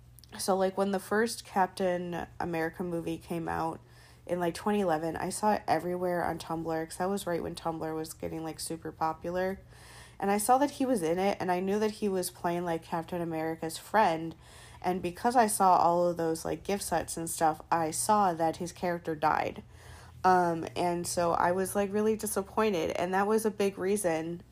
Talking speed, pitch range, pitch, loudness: 200 wpm, 165-195 Hz, 175 Hz, -30 LUFS